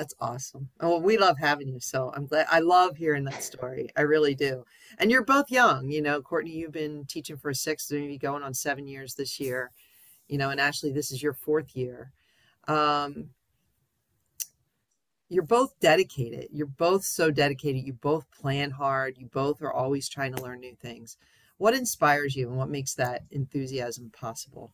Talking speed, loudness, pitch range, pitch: 185 wpm, -27 LUFS, 130-155 Hz, 140 Hz